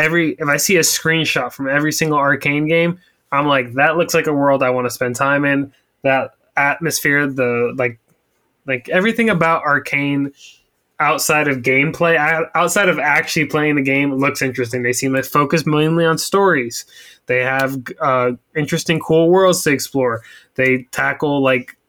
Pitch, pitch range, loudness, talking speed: 145 Hz, 130-160 Hz, -16 LUFS, 170 wpm